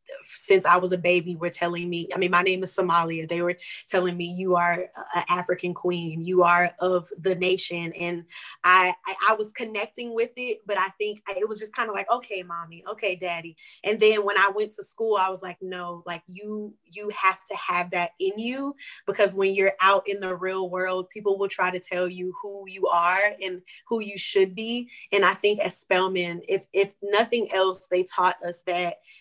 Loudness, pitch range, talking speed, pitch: -25 LUFS, 175-205 Hz, 215 wpm, 185 Hz